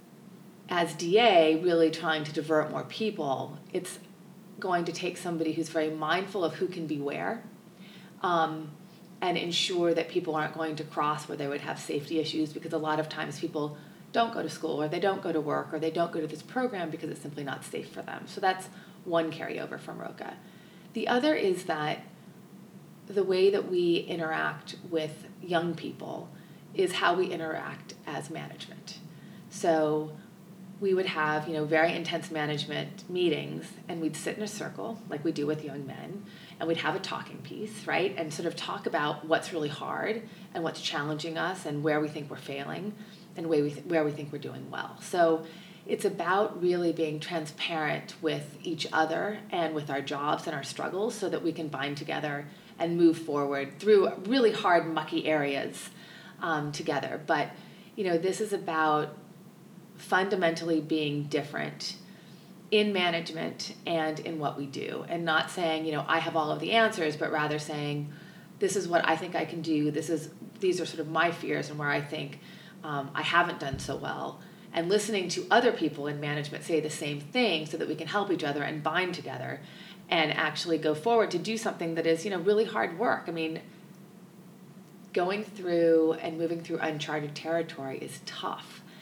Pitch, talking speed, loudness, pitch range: 165 Hz, 190 wpm, -30 LUFS, 155-190 Hz